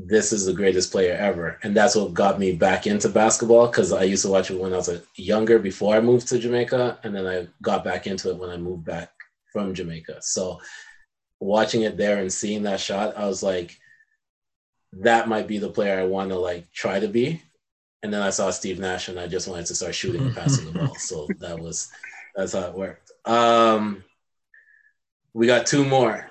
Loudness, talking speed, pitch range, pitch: -22 LUFS, 215 wpm, 95-120 Hz, 105 Hz